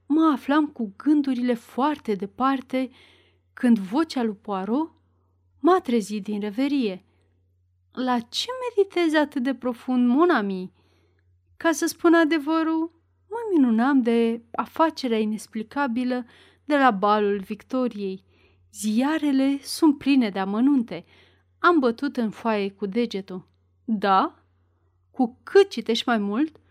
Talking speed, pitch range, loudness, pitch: 115 wpm, 195-285 Hz, -23 LUFS, 235 Hz